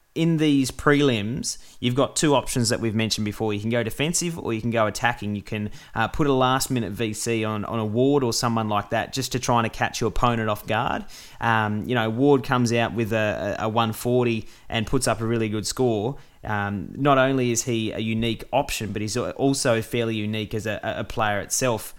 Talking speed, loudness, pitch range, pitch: 220 wpm, -23 LUFS, 110-130 Hz, 115 Hz